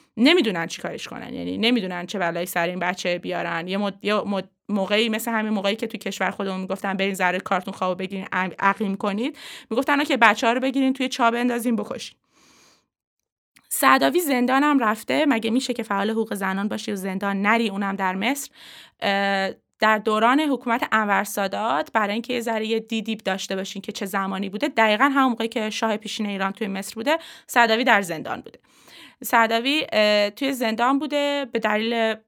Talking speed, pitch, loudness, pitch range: 180 wpm, 220 Hz, -22 LUFS, 195-245 Hz